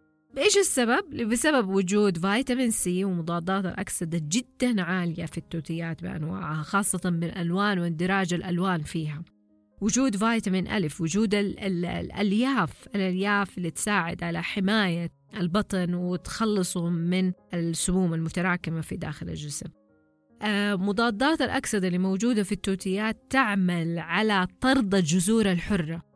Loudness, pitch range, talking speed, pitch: -26 LUFS, 170-210 Hz, 110 wpm, 185 Hz